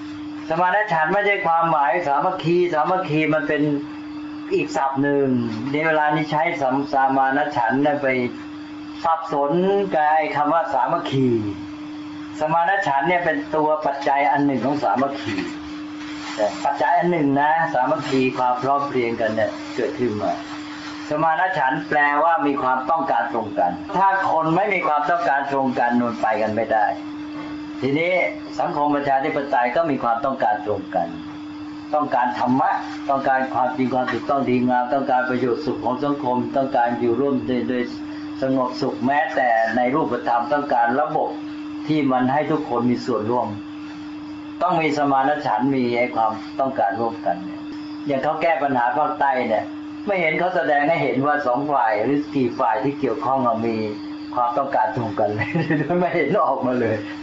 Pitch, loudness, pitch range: 150 Hz, -21 LUFS, 130-180 Hz